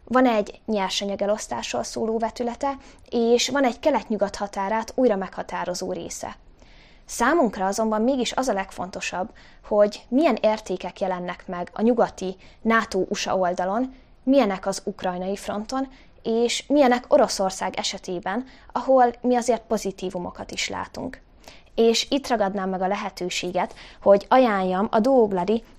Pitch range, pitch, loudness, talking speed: 195-245 Hz, 215 Hz, -23 LUFS, 120 wpm